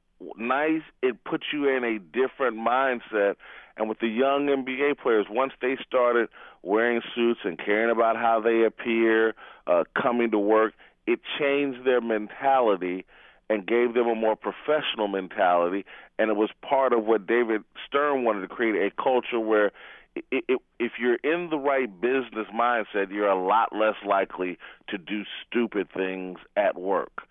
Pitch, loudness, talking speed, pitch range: 115 Hz, -25 LUFS, 165 wpm, 105-130 Hz